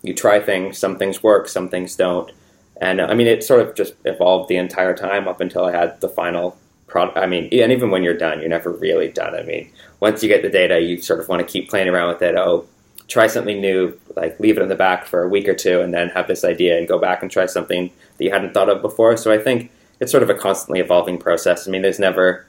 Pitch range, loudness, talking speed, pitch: 90-125 Hz, -18 LUFS, 270 wpm, 95 Hz